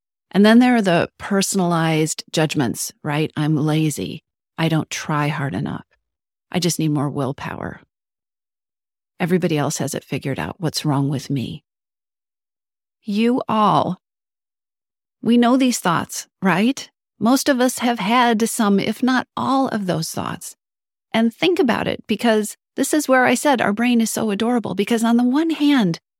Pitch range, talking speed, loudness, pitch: 150-235 Hz, 160 wpm, -19 LUFS, 185 Hz